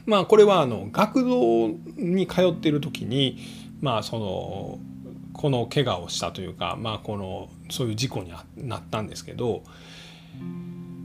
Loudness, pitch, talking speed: -25 LUFS, 120 Hz, 275 characters per minute